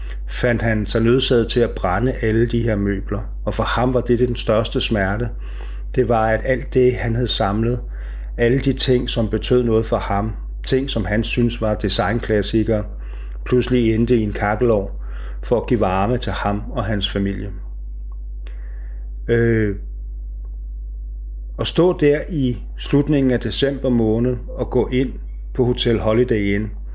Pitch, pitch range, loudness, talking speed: 110 Hz, 95-125 Hz, -19 LUFS, 160 wpm